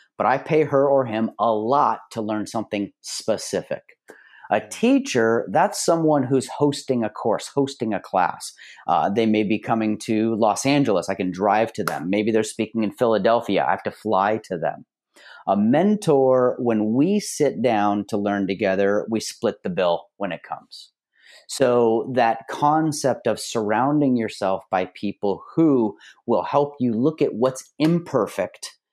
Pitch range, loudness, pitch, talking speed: 105-140 Hz, -22 LUFS, 115 Hz, 165 wpm